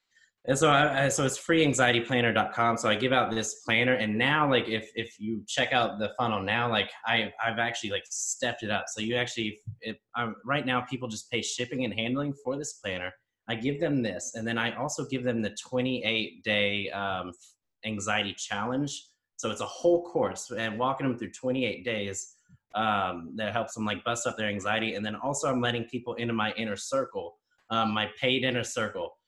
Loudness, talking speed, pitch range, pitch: -29 LUFS, 205 wpm, 110-130 Hz, 115 Hz